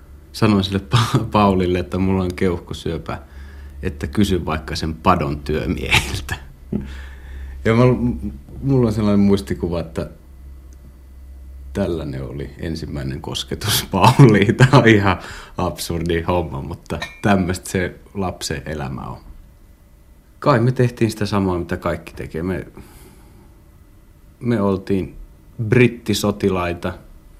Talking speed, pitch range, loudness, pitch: 105 wpm, 70-100 Hz, -19 LUFS, 90 Hz